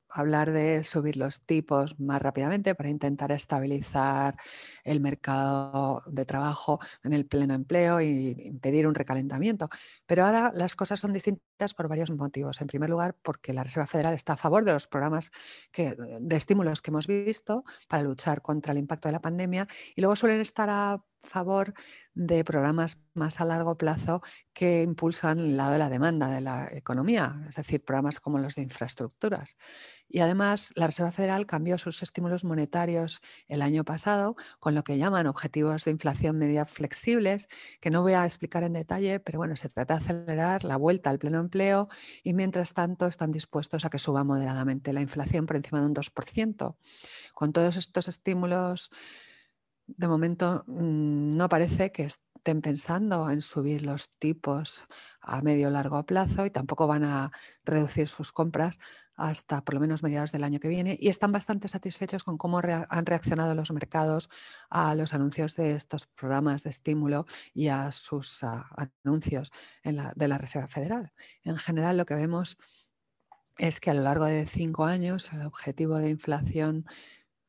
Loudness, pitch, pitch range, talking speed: -29 LUFS, 155 Hz, 145-175 Hz, 175 wpm